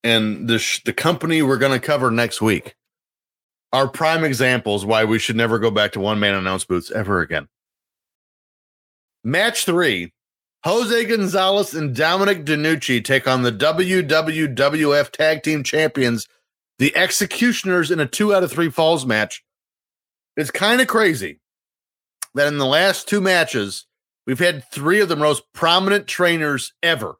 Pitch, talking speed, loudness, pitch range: 145 Hz, 150 wpm, -18 LUFS, 115-170 Hz